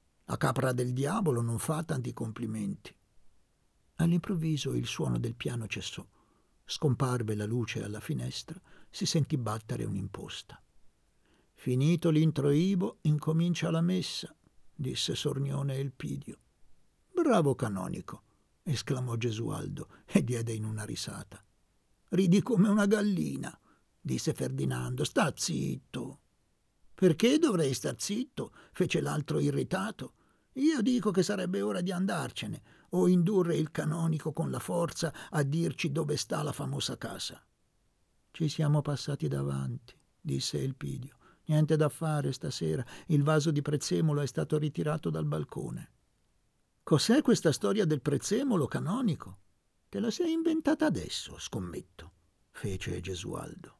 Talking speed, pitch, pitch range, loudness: 120 wpm, 150 Hz, 120-175 Hz, -31 LUFS